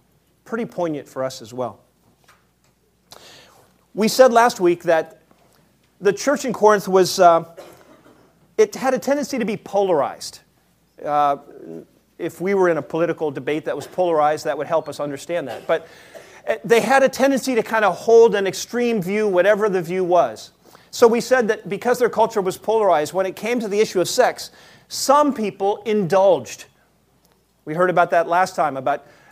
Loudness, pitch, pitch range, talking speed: -19 LUFS, 190 Hz, 165-225 Hz, 170 wpm